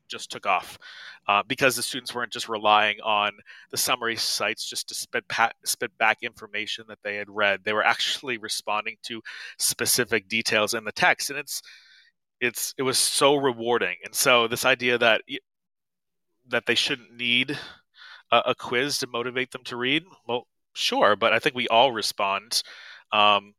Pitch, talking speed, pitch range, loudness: 120 Hz, 175 wpm, 105-130 Hz, -24 LUFS